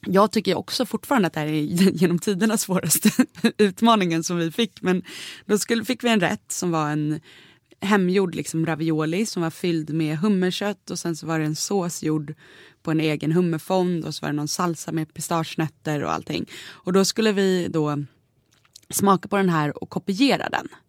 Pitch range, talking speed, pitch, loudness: 155-205 Hz, 190 wpm, 175 Hz, -23 LUFS